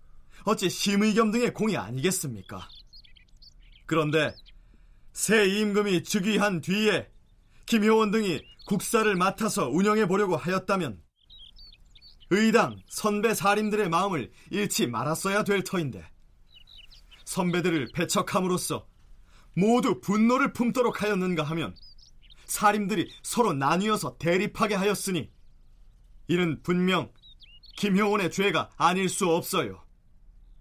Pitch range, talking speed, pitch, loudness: 130-210 Hz, 250 characters per minute, 180 Hz, -26 LUFS